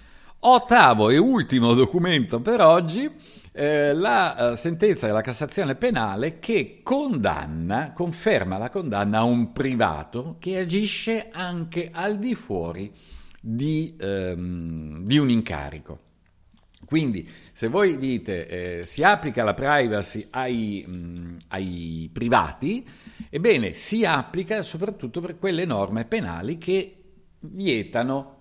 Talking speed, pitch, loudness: 110 wpm, 135 Hz, -23 LUFS